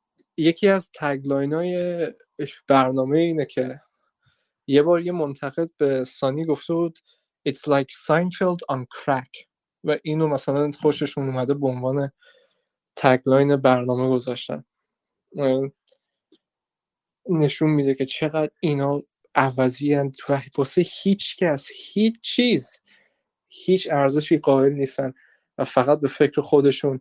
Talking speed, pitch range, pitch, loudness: 115 wpm, 135-165 Hz, 145 Hz, -22 LUFS